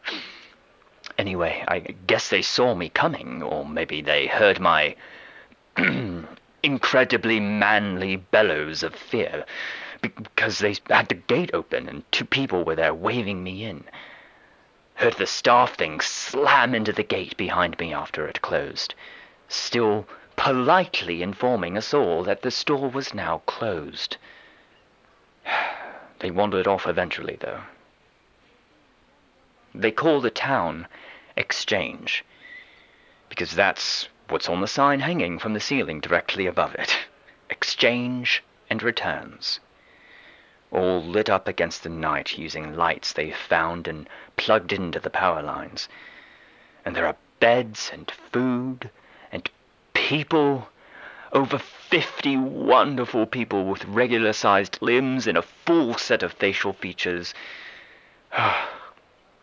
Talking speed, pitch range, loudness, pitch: 120 wpm, 95-135 Hz, -23 LUFS, 115 Hz